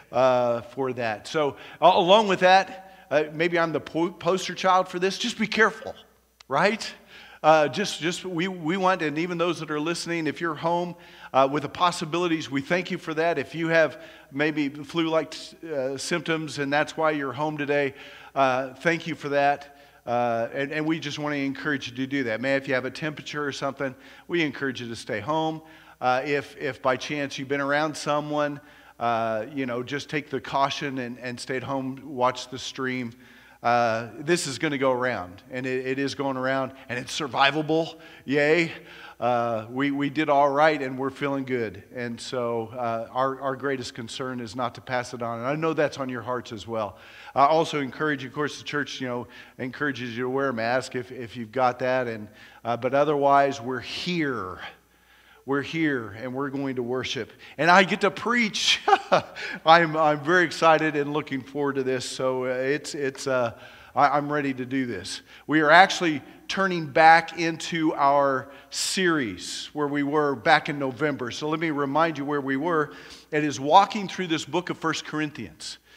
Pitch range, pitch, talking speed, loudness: 130-160 Hz, 145 Hz, 200 wpm, -25 LUFS